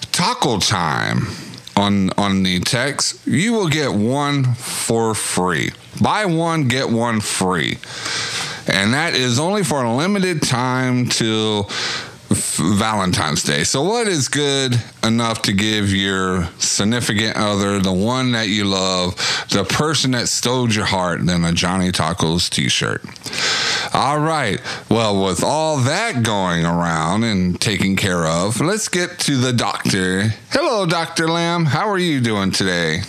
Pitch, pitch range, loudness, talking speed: 110 Hz, 95-140 Hz, -18 LUFS, 145 wpm